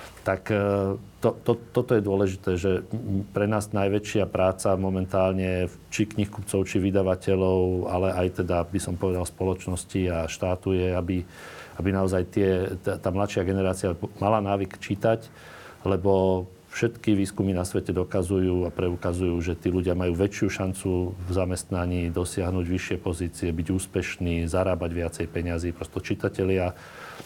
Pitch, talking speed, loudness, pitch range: 95 Hz, 135 wpm, -26 LUFS, 90-100 Hz